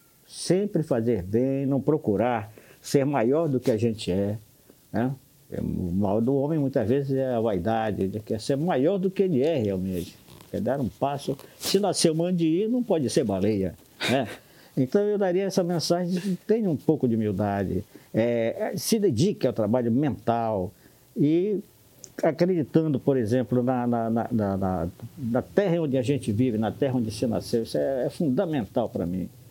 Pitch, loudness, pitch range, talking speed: 130 Hz, -26 LUFS, 110-160 Hz, 170 wpm